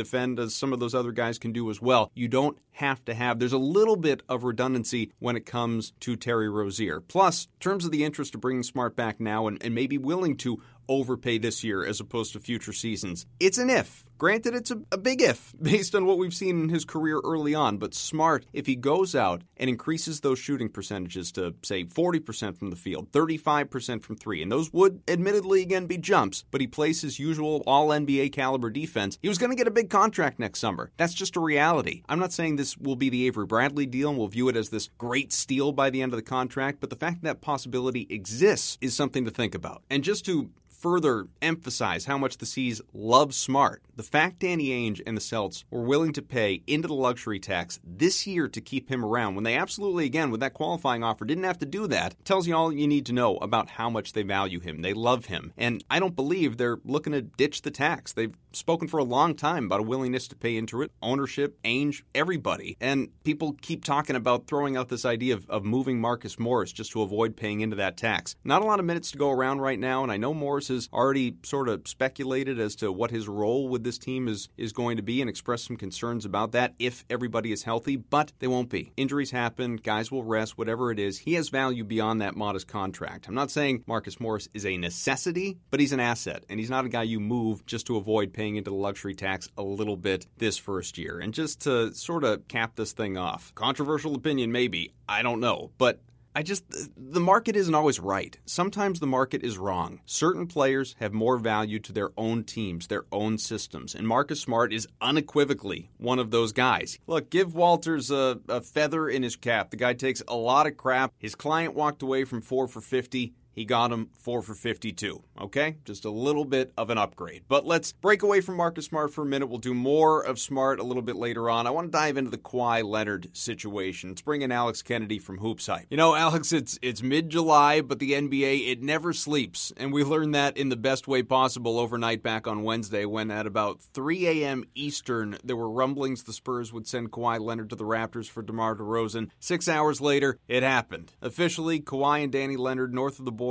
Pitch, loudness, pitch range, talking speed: 125 Hz, -27 LUFS, 115-145 Hz, 225 wpm